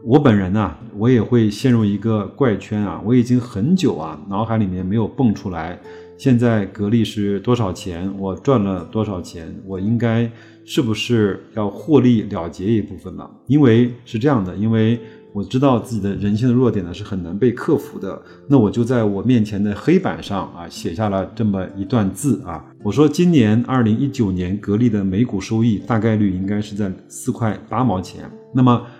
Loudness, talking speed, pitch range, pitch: -18 LUFS, 285 characters per minute, 100-120 Hz, 110 Hz